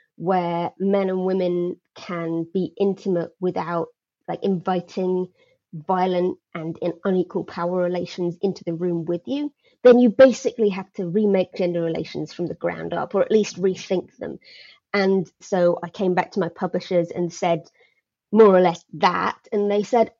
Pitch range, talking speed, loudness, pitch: 175-200 Hz, 165 wpm, -22 LUFS, 185 Hz